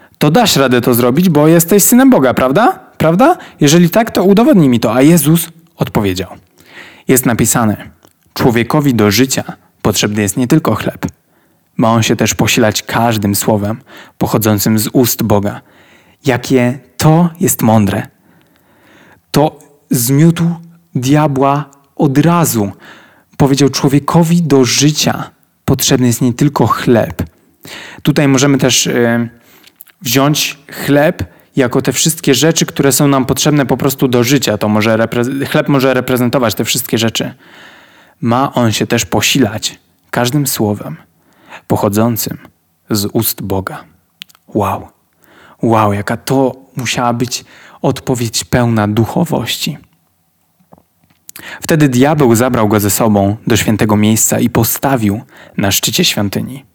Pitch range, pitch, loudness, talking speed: 110-145 Hz, 130 Hz, -12 LUFS, 125 wpm